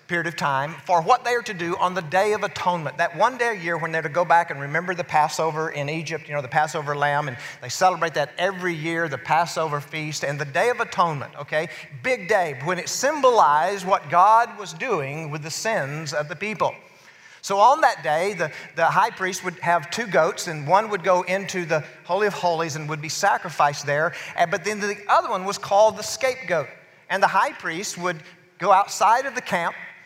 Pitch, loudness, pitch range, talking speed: 170 Hz, -22 LUFS, 155-195 Hz, 220 wpm